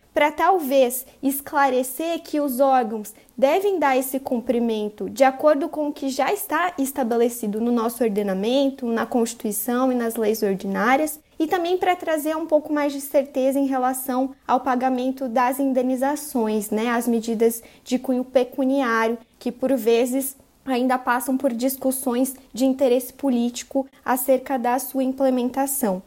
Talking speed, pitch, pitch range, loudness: 145 wpm, 260 Hz, 240-275 Hz, -22 LUFS